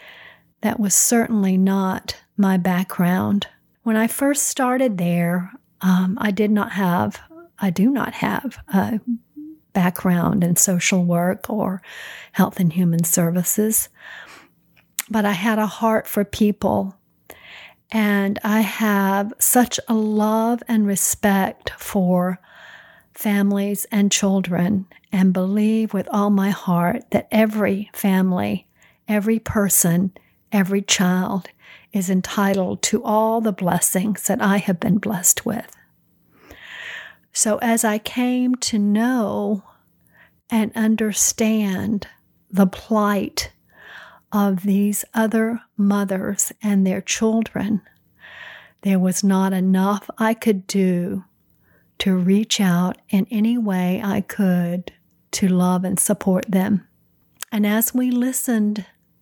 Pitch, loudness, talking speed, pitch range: 200 Hz, -20 LUFS, 115 wpm, 190-220 Hz